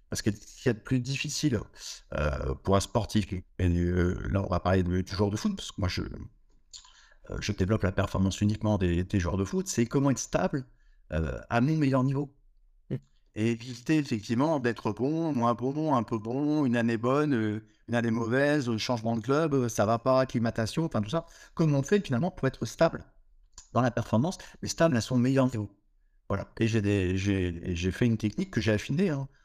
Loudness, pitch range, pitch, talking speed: -29 LUFS, 100-135 Hz, 115 Hz, 210 wpm